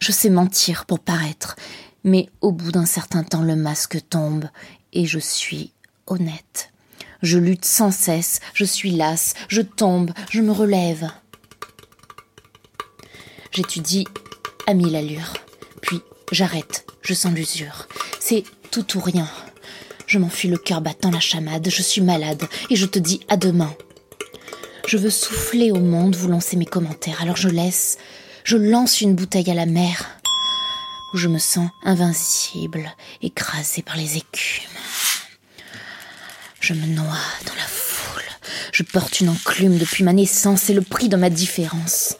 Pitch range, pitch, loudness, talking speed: 165-200 Hz, 180 Hz, -19 LUFS, 150 wpm